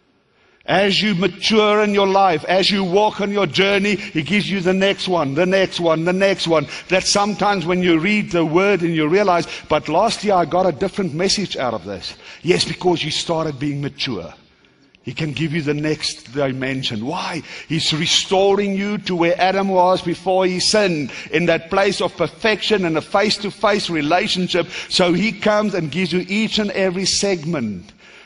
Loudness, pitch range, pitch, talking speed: -18 LUFS, 165-200 Hz, 185 Hz, 190 wpm